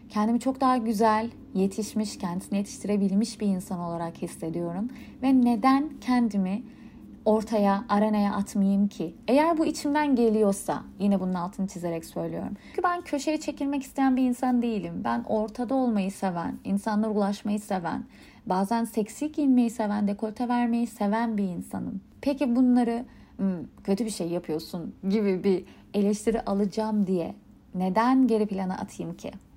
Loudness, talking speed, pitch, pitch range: -27 LUFS, 135 wpm, 215 Hz, 195-245 Hz